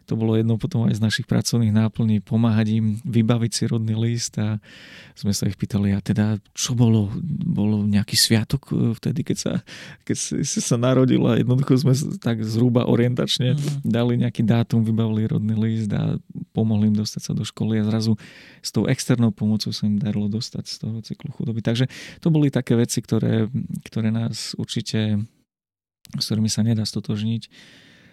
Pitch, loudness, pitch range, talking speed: 115 Hz, -22 LUFS, 110-125 Hz, 175 wpm